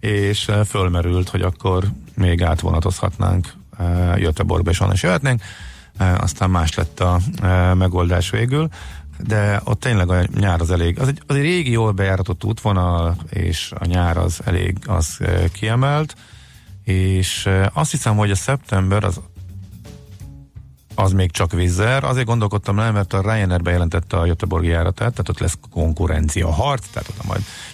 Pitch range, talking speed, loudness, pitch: 90-105 Hz, 145 wpm, -19 LUFS, 95 Hz